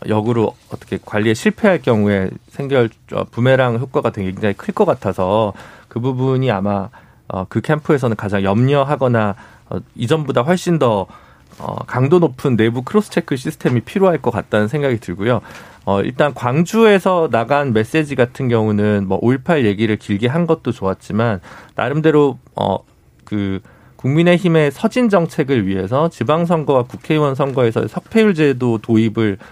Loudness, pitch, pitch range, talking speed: -16 LUFS, 125 Hz, 110-155 Hz, 325 characters per minute